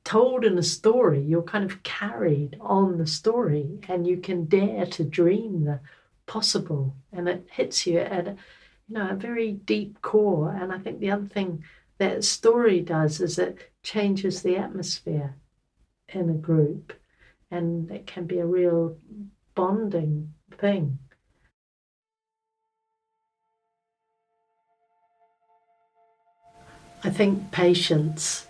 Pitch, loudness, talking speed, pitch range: 185 Hz, -25 LUFS, 125 wpm, 170-220 Hz